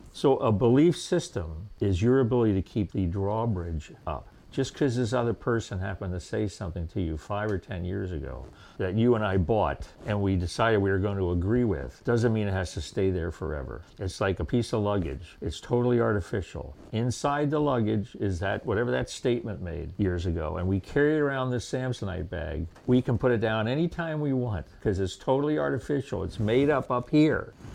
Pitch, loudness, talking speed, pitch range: 105 Hz, -28 LUFS, 205 wpm, 90-125 Hz